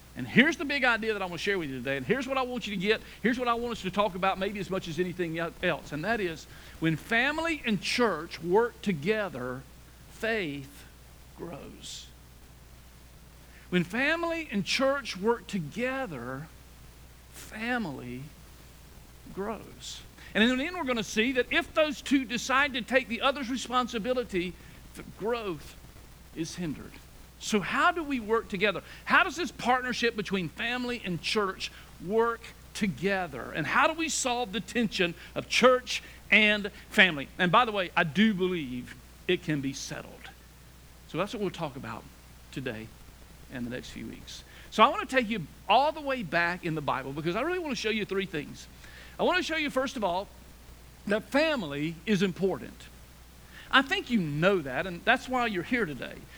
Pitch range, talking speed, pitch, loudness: 155-245 Hz, 180 wpm, 200 Hz, -28 LUFS